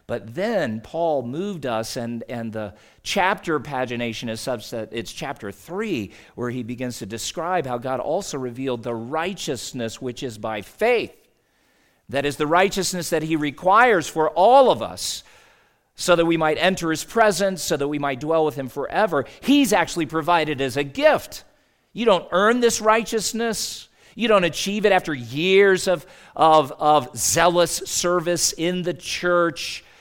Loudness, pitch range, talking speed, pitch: -21 LUFS, 125-180 Hz, 160 wpm, 155 Hz